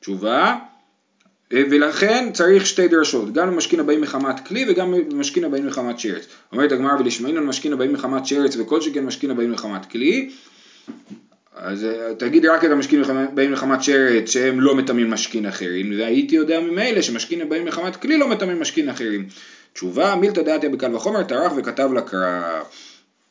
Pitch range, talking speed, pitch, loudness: 120-170 Hz, 160 wpm, 140 Hz, -19 LUFS